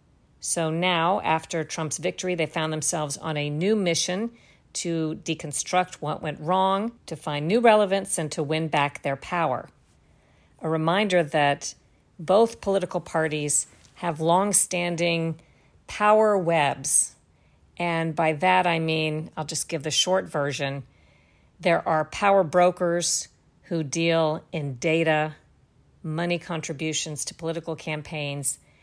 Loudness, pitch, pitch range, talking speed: -24 LUFS, 160 Hz, 155-180 Hz, 130 wpm